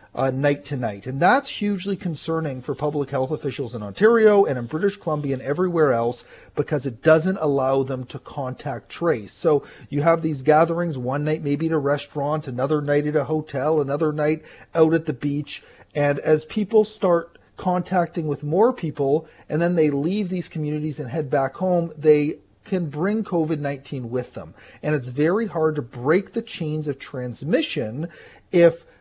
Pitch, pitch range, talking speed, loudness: 155 Hz, 140-170 Hz, 180 wpm, -22 LUFS